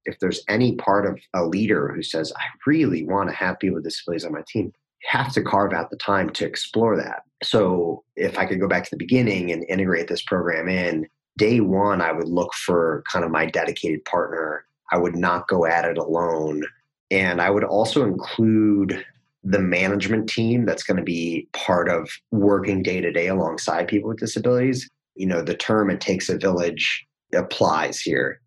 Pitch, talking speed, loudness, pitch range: 95 Hz, 195 wpm, -22 LUFS, 85-110 Hz